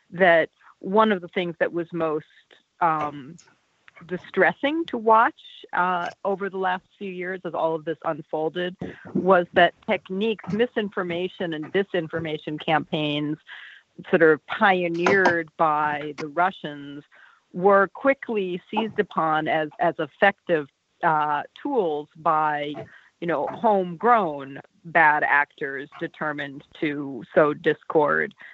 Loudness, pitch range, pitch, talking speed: -23 LUFS, 155-195 Hz, 175 Hz, 115 wpm